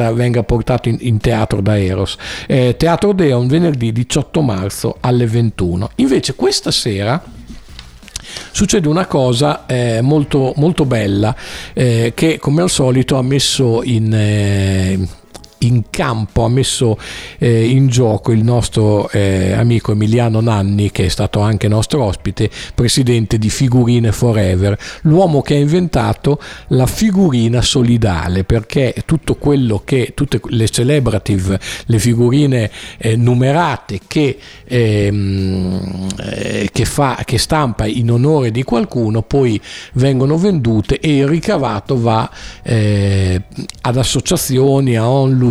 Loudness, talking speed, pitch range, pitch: -14 LUFS, 130 wpm, 105-135 Hz, 120 Hz